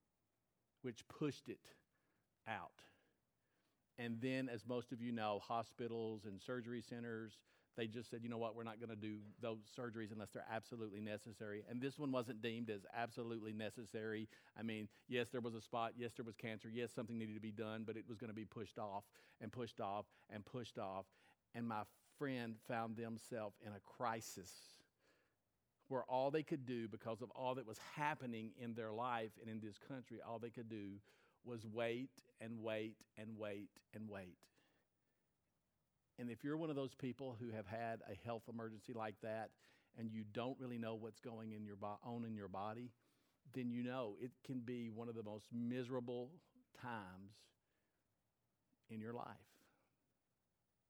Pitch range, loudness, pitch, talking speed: 110-125 Hz, -49 LUFS, 115 Hz, 175 wpm